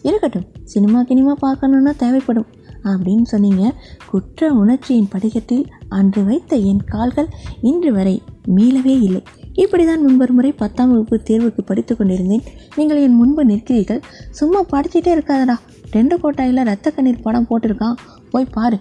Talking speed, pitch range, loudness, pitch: 130 wpm, 215-275 Hz, -15 LUFS, 245 Hz